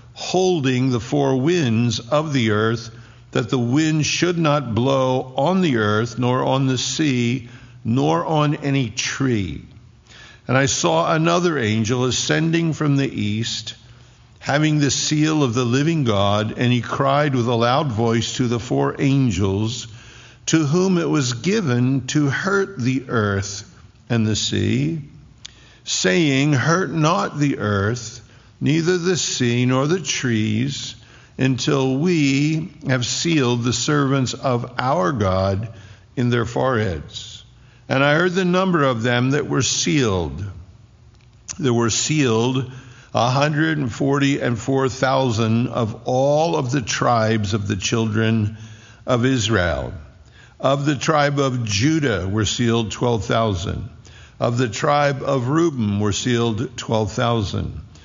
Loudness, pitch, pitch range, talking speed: -19 LUFS, 125 Hz, 115-145 Hz, 140 wpm